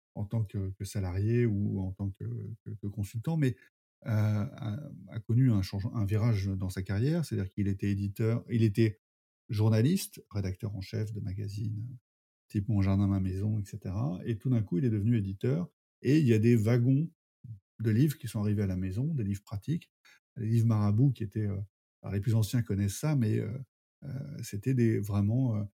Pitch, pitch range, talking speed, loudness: 110 Hz, 100-120 Hz, 200 wpm, -31 LUFS